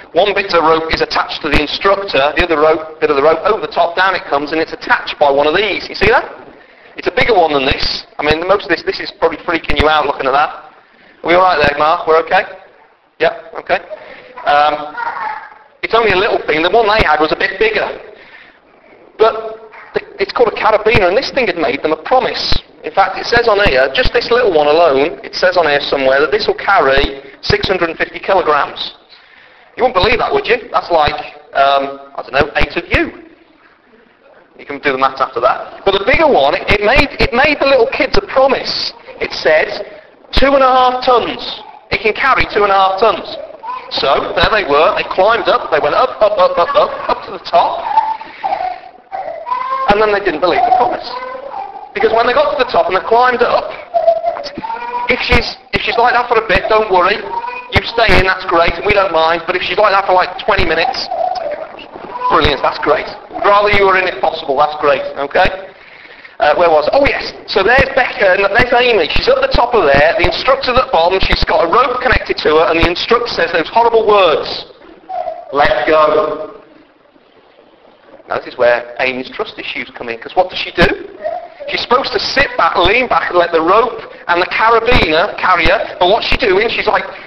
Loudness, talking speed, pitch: -13 LUFS, 215 wpm, 205 Hz